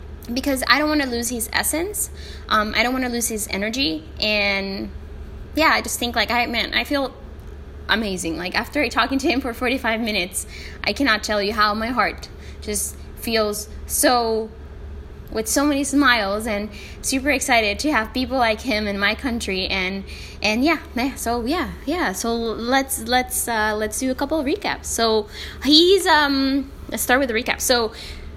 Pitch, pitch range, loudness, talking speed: 235 Hz, 215-270 Hz, -20 LUFS, 180 wpm